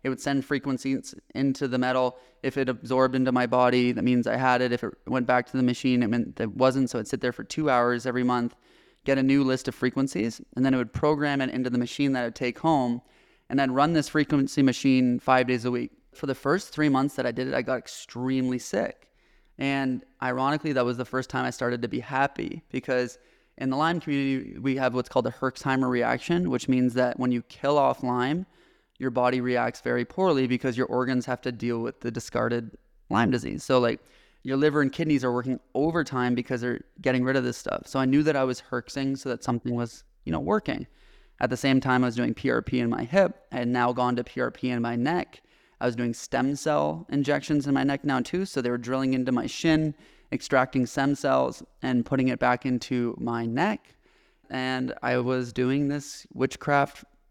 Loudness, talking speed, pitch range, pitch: -26 LUFS, 225 wpm, 125-135 Hz, 130 Hz